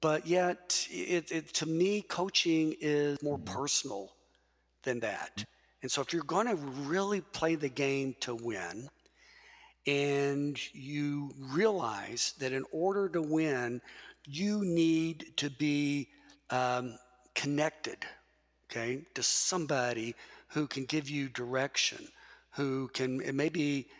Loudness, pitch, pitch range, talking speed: -33 LUFS, 145 Hz, 130-170 Hz, 125 wpm